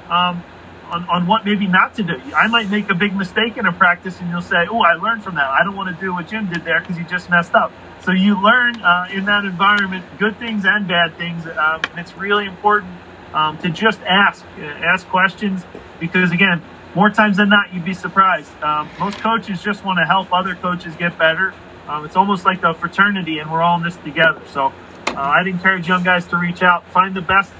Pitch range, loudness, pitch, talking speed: 175-200 Hz, -16 LUFS, 185 Hz, 235 wpm